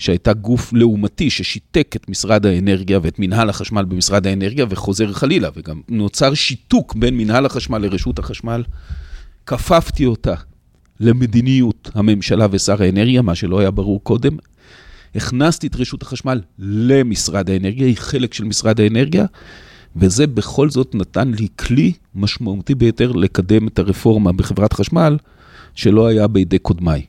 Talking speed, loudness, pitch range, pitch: 135 wpm, -16 LUFS, 95-125 Hz, 110 Hz